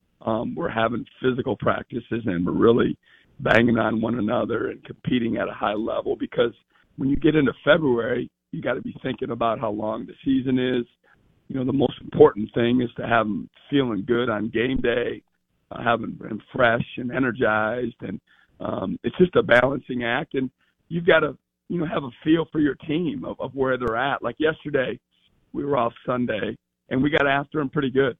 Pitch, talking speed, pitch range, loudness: 125 Hz, 200 wpm, 115-140 Hz, -23 LUFS